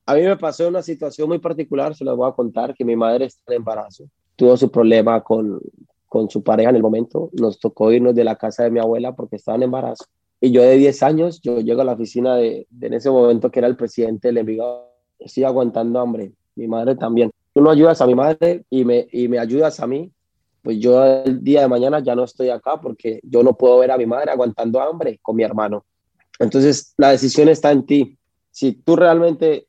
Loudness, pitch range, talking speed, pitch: -16 LUFS, 115-140 Hz, 230 wpm, 125 Hz